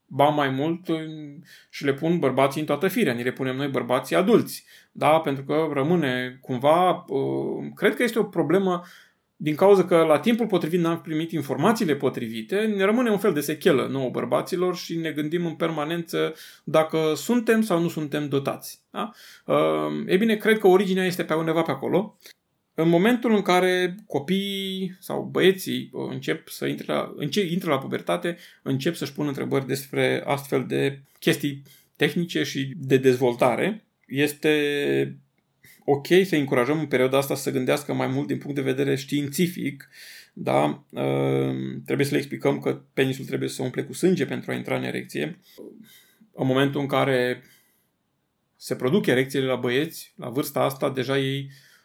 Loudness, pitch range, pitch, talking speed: -24 LUFS, 130-175 Hz, 145 Hz, 160 wpm